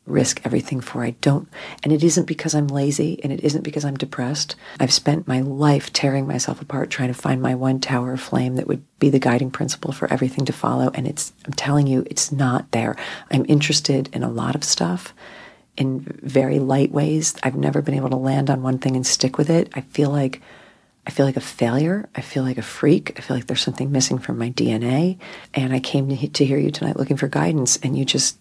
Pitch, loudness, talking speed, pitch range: 140 Hz, -21 LUFS, 235 wpm, 130-150 Hz